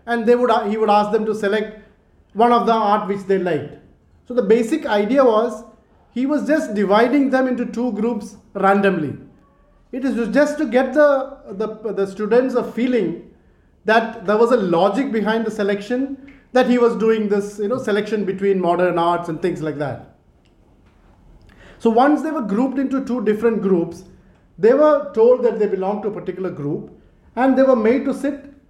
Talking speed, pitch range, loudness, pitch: 185 wpm, 200-255 Hz, -18 LUFS, 225 Hz